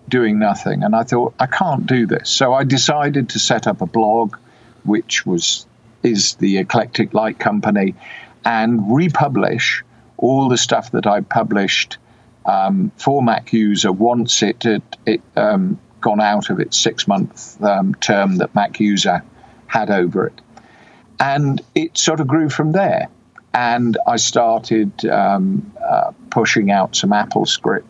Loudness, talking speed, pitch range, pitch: -16 LUFS, 155 wpm, 105-155 Hz, 120 Hz